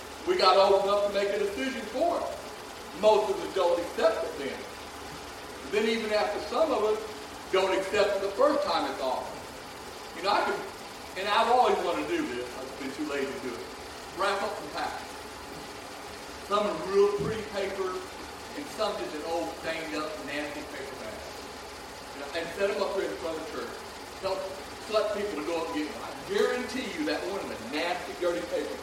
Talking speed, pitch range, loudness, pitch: 205 wpm, 185-215 Hz, -29 LUFS, 200 Hz